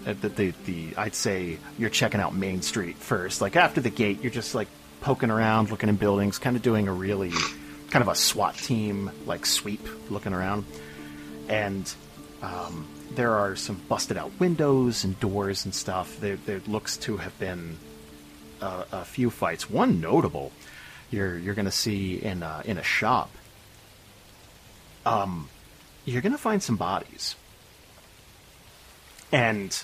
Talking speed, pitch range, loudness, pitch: 155 wpm, 85-105 Hz, -27 LUFS, 100 Hz